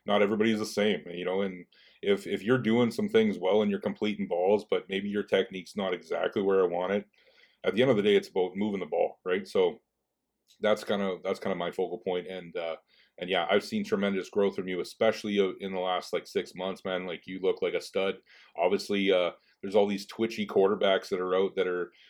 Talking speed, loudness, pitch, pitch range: 235 wpm, -29 LUFS, 100 Hz, 95-115 Hz